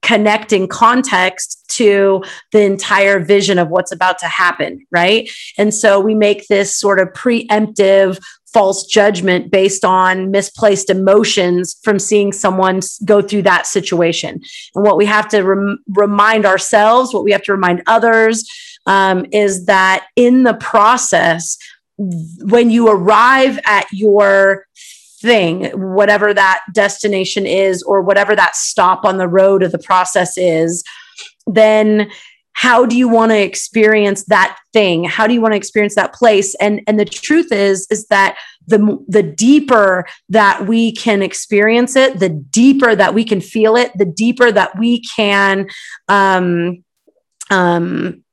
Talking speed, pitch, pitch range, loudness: 150 wpm, 205 Hz, 190-220 Hz, -12 LUFS